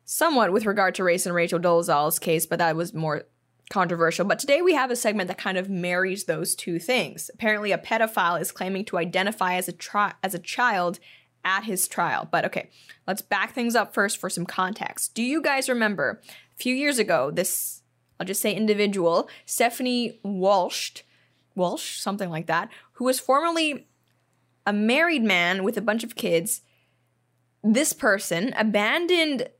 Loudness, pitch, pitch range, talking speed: -24 LUFS, 195 Hz, 175-230 Hz, 175 wpm